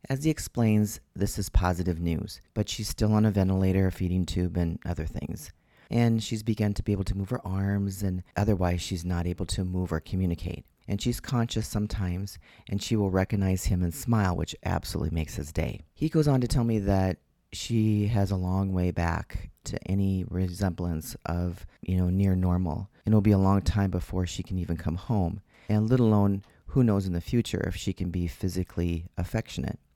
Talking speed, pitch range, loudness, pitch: 200 wpm, 90-105 Hz, -28 LUFS, 95 Hz